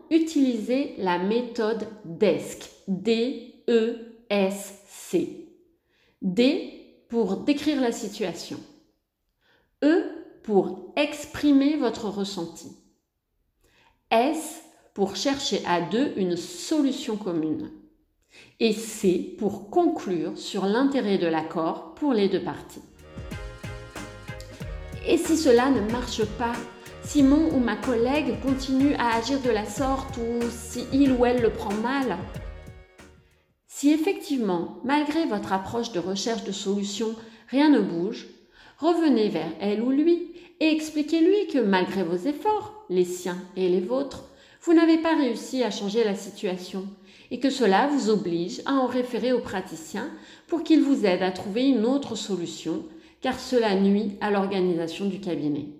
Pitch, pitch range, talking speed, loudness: 230 Hz, 190-280 Hz, 130 wpm, -25 LUFS